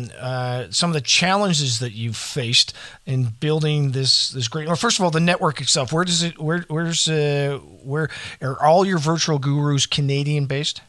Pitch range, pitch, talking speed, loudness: 130-160 Hz, 145 Hz, 190 wpm, -20 LUFS